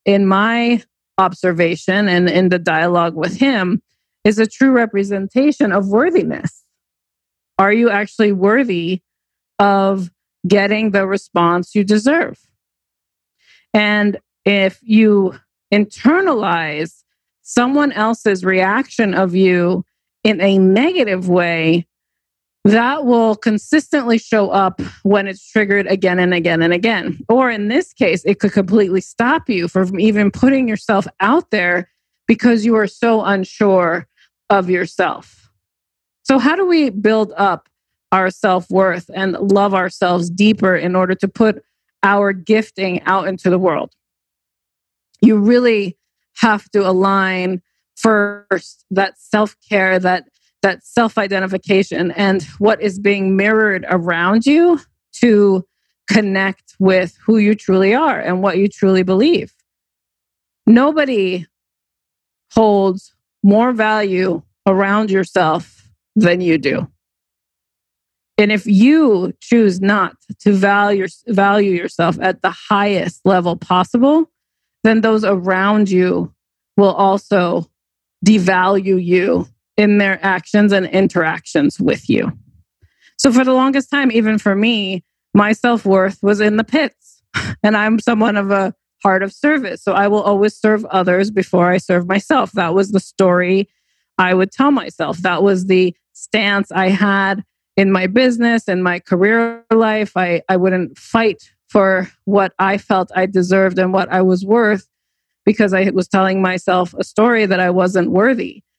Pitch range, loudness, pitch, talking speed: 185-215 Hz, -15 LUFS, 195 Hz, 135 wpm